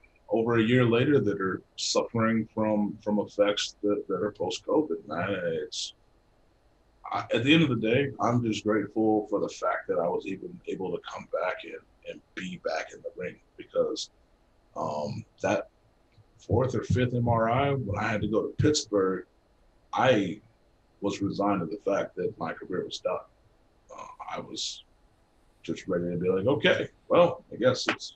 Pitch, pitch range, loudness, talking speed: 115 Hz, 105-140 Hz, -28 LUFS, 175 wpm